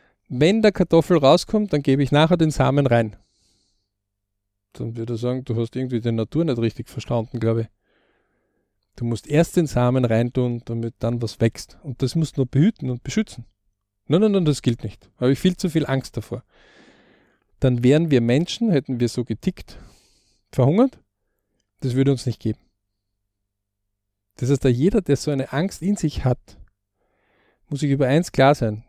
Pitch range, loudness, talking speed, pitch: 110-150 Hz, -21 LUFS, 185 wpm, 125 Hz